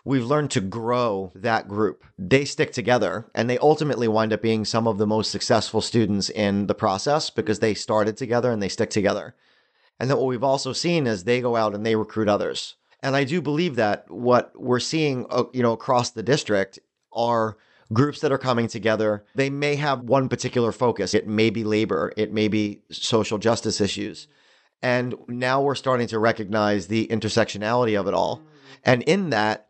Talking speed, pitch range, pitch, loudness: 190 wpm, 110-130 Hz, 115 Hz, -23 LUFS